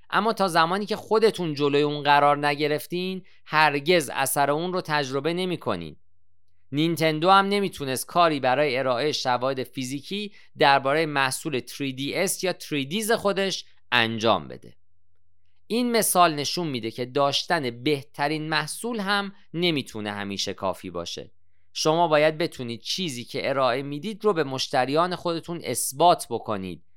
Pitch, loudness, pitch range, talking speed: 145 Hz, -24 LUFS, 125-175 Hz, 125 wpm